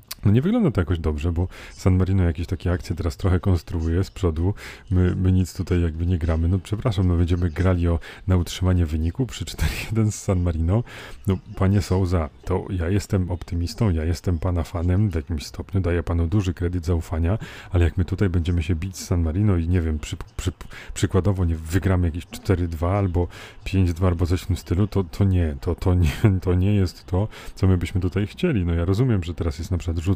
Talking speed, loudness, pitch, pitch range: 215 wpm, -23 LUFS, 90 Hz, 85-95 Hz